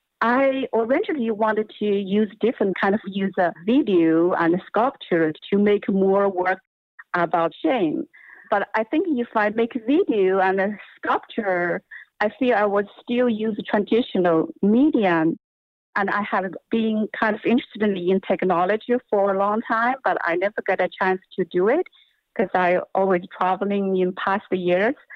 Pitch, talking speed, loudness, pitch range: 205 Hz, 155 wpm, -22 LUFS, 185-230 Hz